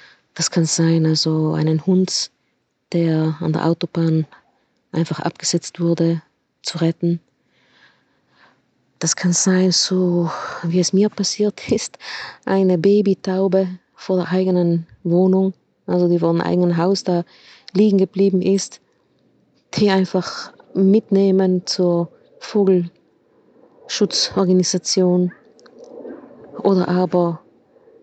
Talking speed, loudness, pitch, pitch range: 100 wpm, -18 LUFS, 180 Hz, 170-190 Hz